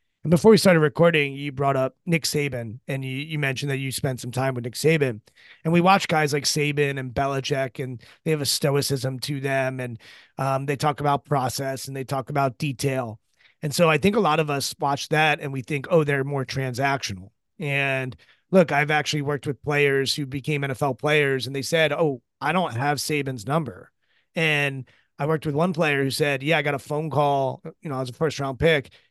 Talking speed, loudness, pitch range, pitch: 215 wpm, -23 LUFS, 135-150 Hz, 140 Hz